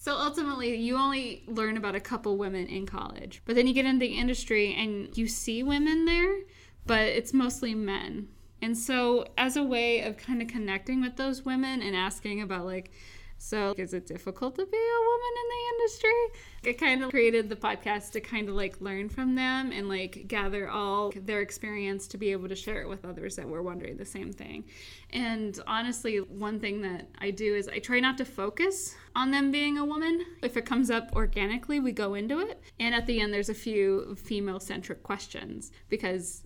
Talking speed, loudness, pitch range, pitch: 205 wpm, -30 LUFS, 200-260 Hz, 225 Hz